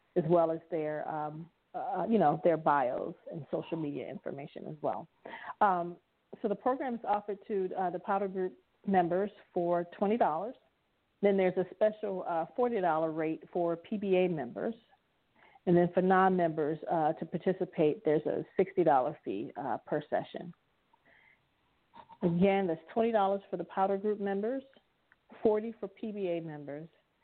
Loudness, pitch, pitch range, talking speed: -32 LUFS, 185 Hz, 170-205 Hz, 155 wpm